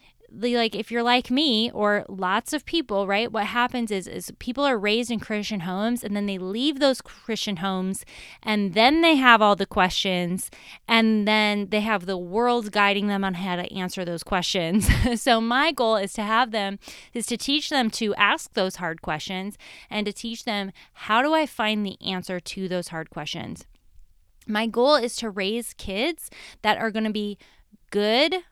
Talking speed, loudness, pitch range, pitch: 190 wpm, -23 LUFS, 195-235 Hz, 215 Hz